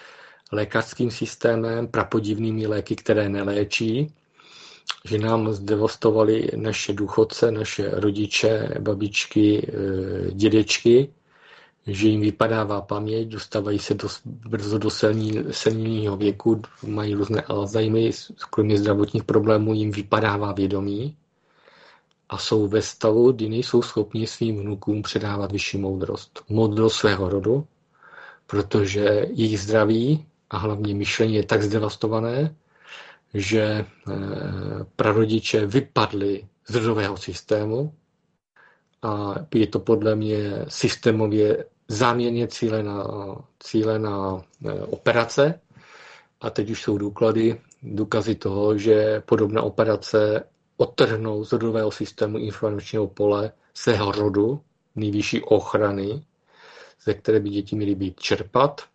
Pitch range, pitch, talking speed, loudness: 105-115 Hz, 110 Hz, 110 wpm, -23 LUFS